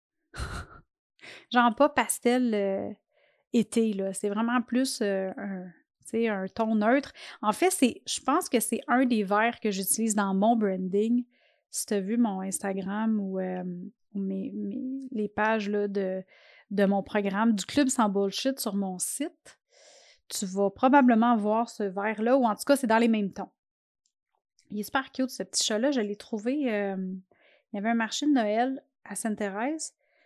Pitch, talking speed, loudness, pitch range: 220 Hz, 175 wpm, -27 LUFS, 200-255 Hz